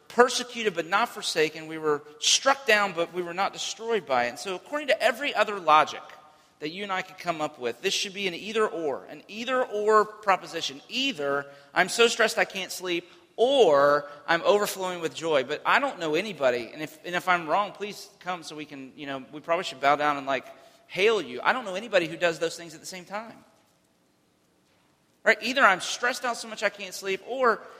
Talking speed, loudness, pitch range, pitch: 235 wpm, -26 LUFS, 155-215 Hz, 180 Hz